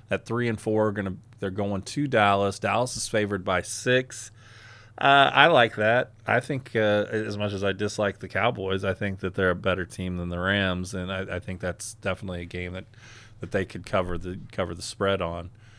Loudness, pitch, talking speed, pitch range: -26 LUFS, 100 Hz, 215 wpm, 95-110 Hz